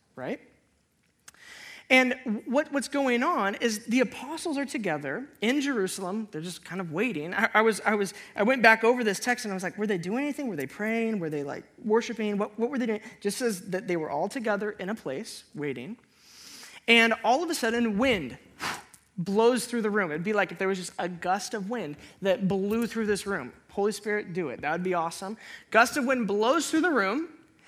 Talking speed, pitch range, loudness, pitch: 220 wpm, 195-245 Hz, -27 LUFS, 215 Hz